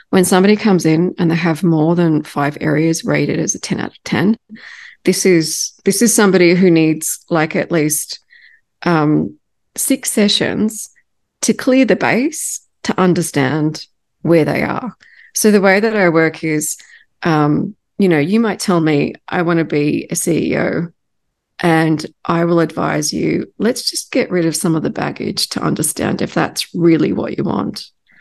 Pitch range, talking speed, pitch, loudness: 160-215 Hz, 175 wpm, 175 Hz, -15 LUFS